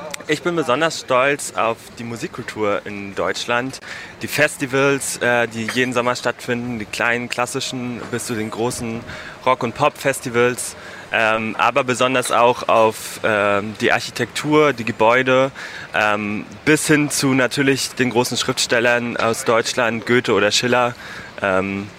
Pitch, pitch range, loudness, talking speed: 120 Hz, 110-130 Hz, -19 LUFS, 125 wpm